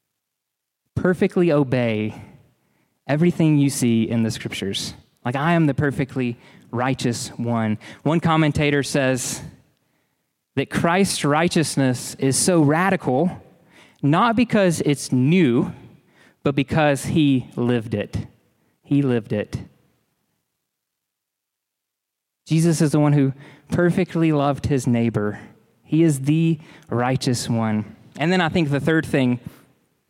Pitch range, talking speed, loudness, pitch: 120-160 Hz, 115 wpm, -20 LUFS, 140 Hz